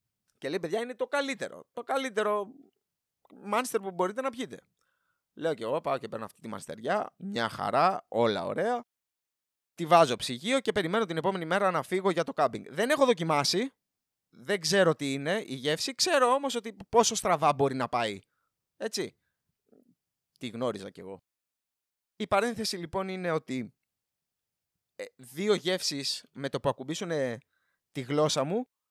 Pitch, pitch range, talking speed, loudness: 195 Hz, 150-240 Hz, 160 wpm, -29 LUFS